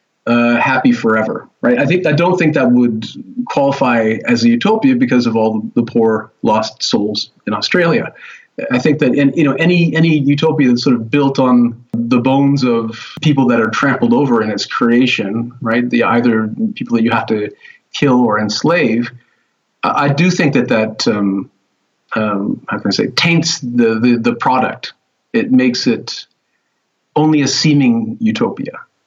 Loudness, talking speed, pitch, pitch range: -14 LUFS, 175 wpm, 125 Hz, 115-155 Hz